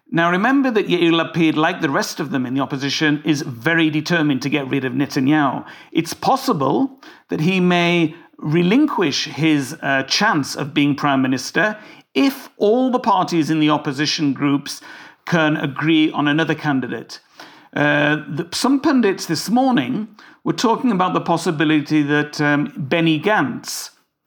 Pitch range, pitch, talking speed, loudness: 145-180 Hz, 160 Hz, 155 wpm, -18 LUFS